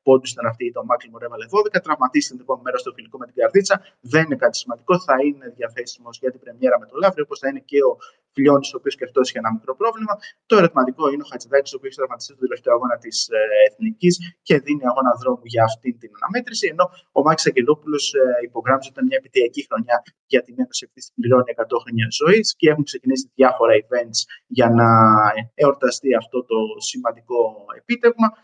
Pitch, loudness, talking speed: 155 Hz, -19 LUFS, 200 wpm